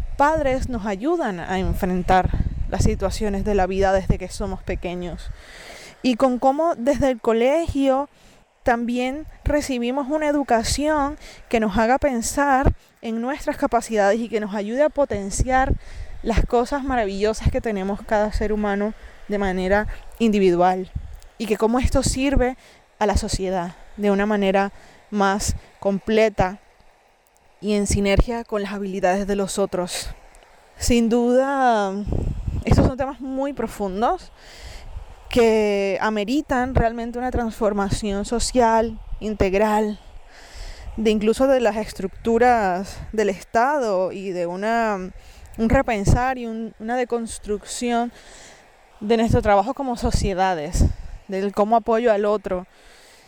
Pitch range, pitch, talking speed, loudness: 200-250 Hz, 220 Hz, 125 wpm, -22 LUFS